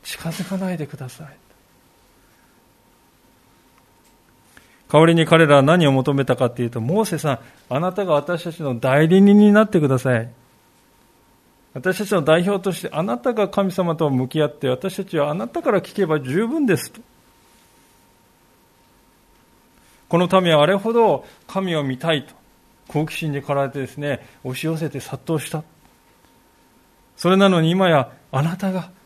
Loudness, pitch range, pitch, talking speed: -19 LUFS, 140-190 Hz, 160 Hz, 275 characters per minute